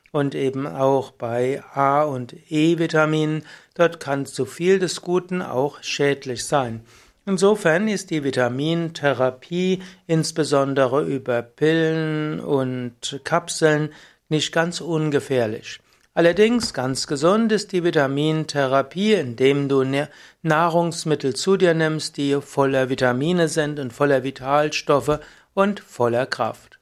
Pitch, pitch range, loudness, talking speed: 150 Hz, 135-170 Hz, -21 LUFS, 110 wpm